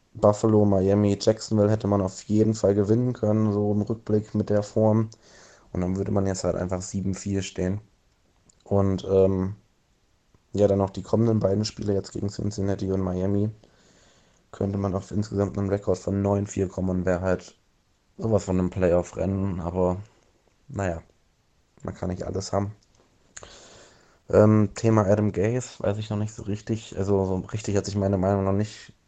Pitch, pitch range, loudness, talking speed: 100 Hz, 95-105 Hz, -25 LUFS, 165 wpm